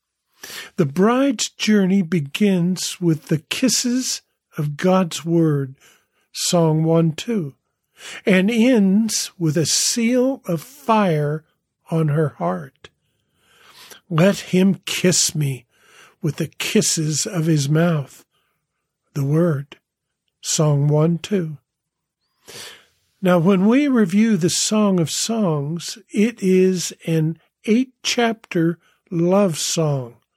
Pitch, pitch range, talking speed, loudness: 175 Hz, 155-210 Hz, 105 wpm, -19 LUFS